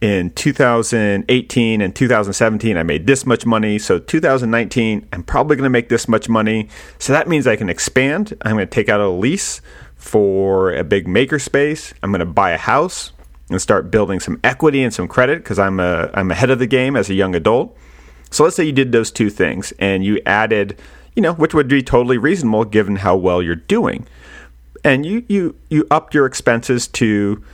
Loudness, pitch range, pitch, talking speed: -16 LUFS, 100-135 Hz, 115 Hz, 205 wpm